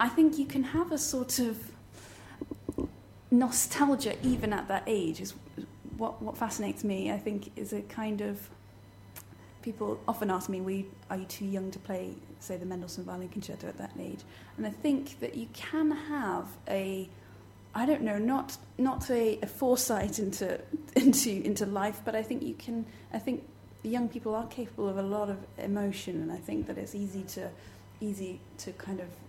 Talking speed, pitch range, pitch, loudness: 185 wpm, 190-245 Hz, 210 Hz, -33 LUFS